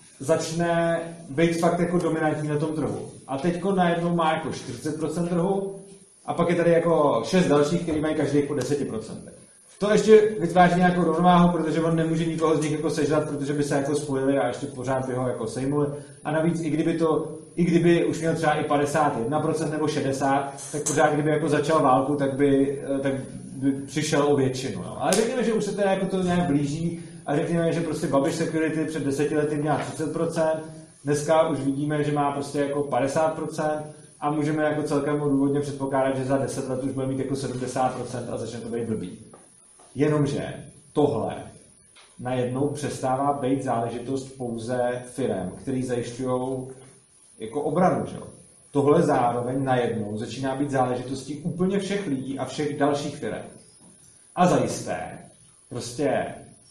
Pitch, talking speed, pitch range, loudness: 150 Hz, 165 wpm, 135-160 Hz, -24 LUFS